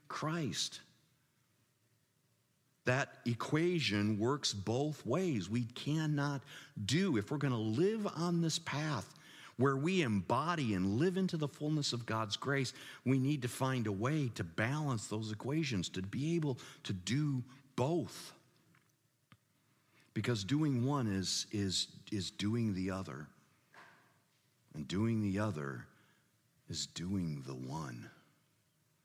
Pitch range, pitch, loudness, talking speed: 105-150 Hz, 130 Hz, -36 LUFS, 125 wpm